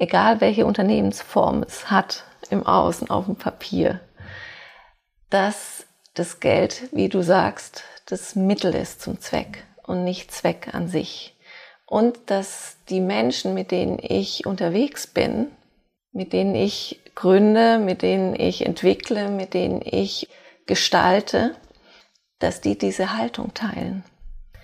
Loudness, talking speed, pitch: -22 LUFS, 125 wpm, 185 Hz